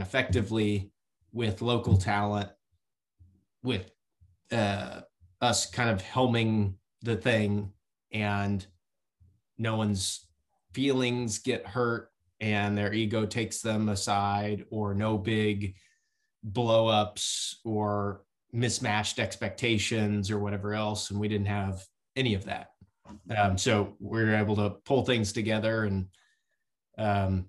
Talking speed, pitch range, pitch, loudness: 115 wpm, 100-115 Hz, 105 Hz, -29 LUFS